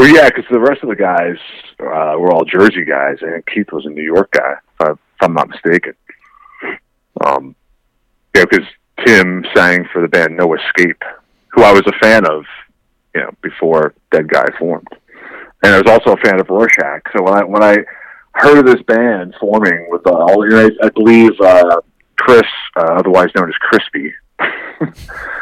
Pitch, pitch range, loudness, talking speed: 100 Hz, 85-110 Hz, -11 LUFS, 175 wpm